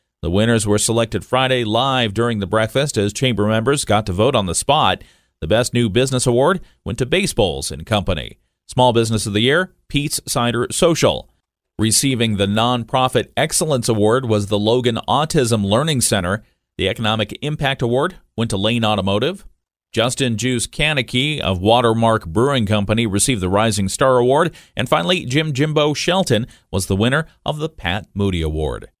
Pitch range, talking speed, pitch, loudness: 105-130 Hz, 165 wpm, 115 Hz, -18 LUFS